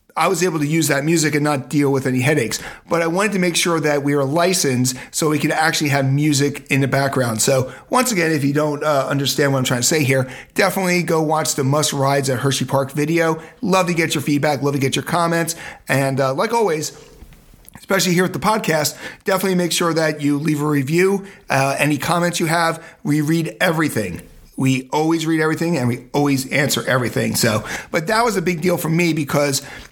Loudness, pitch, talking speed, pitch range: -18 LUFS, 150 Hz, 220 wpm, 135-170 Hz